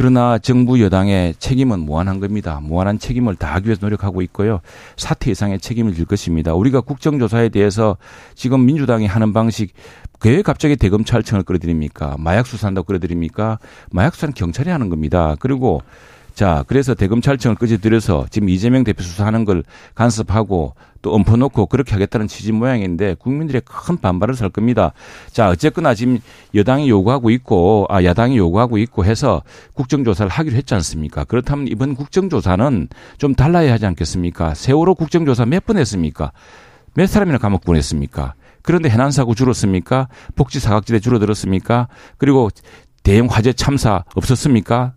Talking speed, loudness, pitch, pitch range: 405 characters per minute, -16 LUFS, 110 Hz, 95-130 Hz